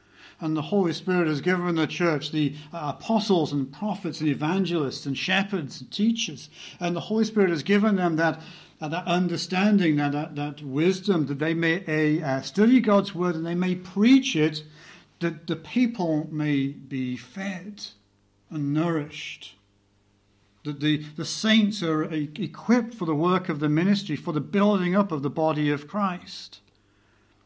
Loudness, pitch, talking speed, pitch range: -25 LUFS, 160 Hz, 165 wpm, 145-185 Hz